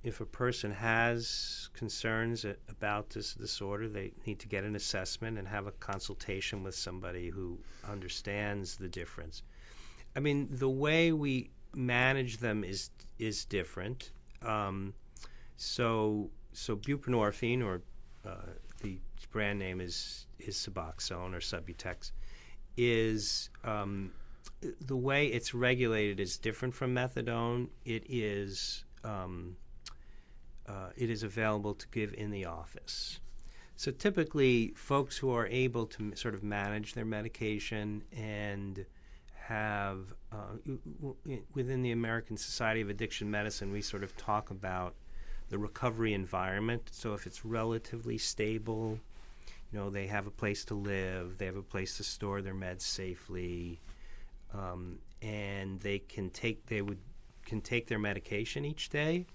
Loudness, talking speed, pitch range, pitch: -36 LUFS, 140 wpm, 95-115 Hz, 105 Hz